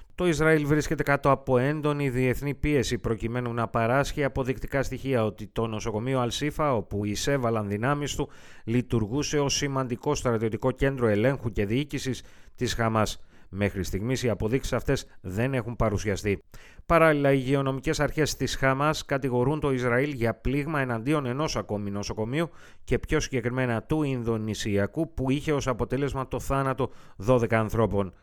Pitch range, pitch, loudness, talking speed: 115-140 Hz, 130 Hz, -27 LUFS, 140 wpm